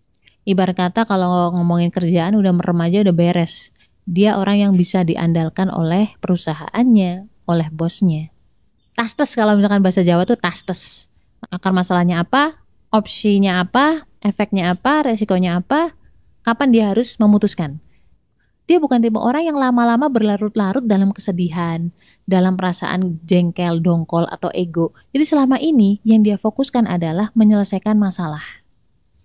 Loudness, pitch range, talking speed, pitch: -17 LUFS, 175-220 Hz, 130 wpm, 195 Hz